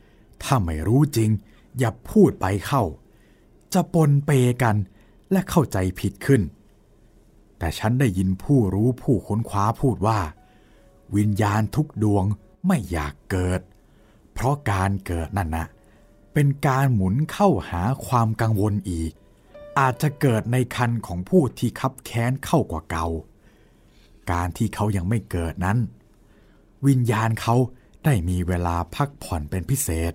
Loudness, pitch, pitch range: -23 LUFS, 110 Hz, 95-130 Hz